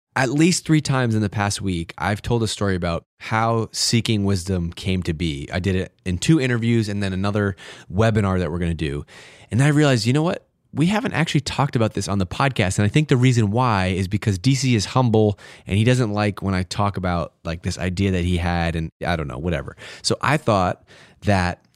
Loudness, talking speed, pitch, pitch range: -21 LUFS, 230 wpm, 100 Hz, 90-125 Hz